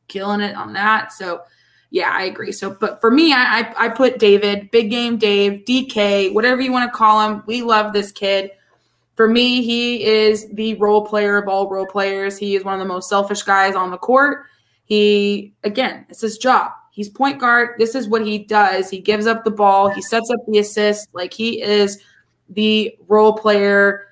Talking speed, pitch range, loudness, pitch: 205 wpm, 200-230 Hz, -16 LUFS, 210 Hz